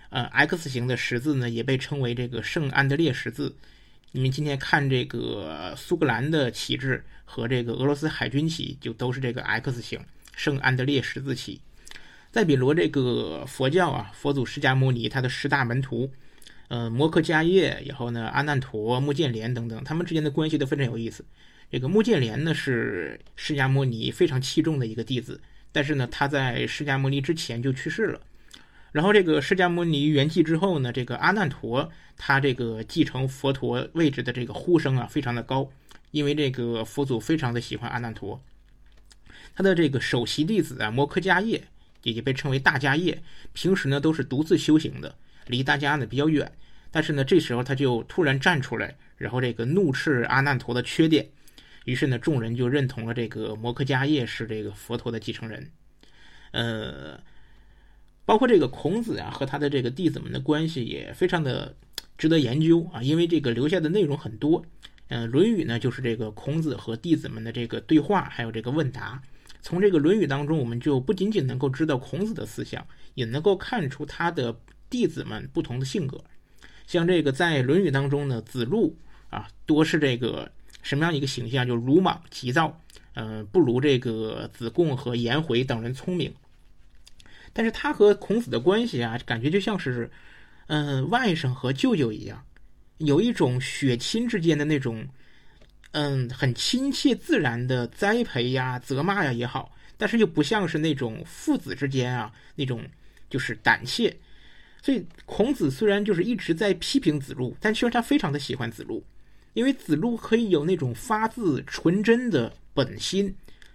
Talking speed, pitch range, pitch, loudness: 280 characters per minute, 120-160 Hz, 140 Hz, -25 LUFS